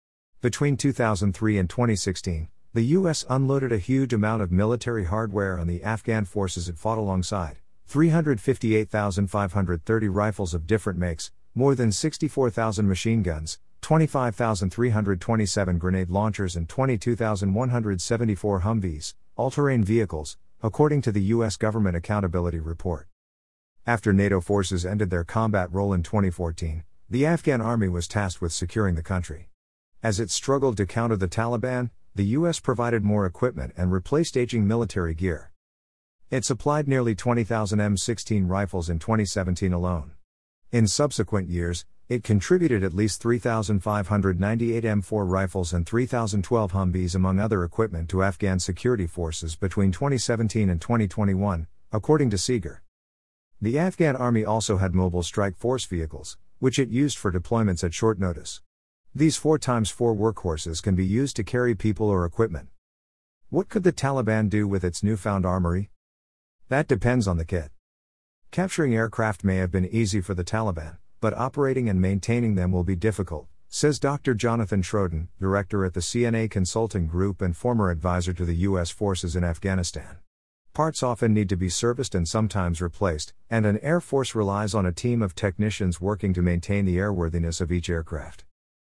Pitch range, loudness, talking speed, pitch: 90-115 Hz, -25 LUFS, 150 wpm, 100 Hz